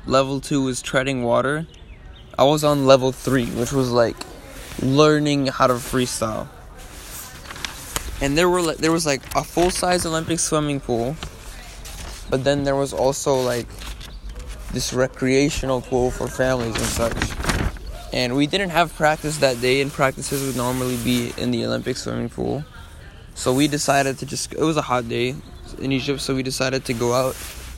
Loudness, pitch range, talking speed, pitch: -21 LUFS, 125-145 Hz, 165 wpm, 130 Hz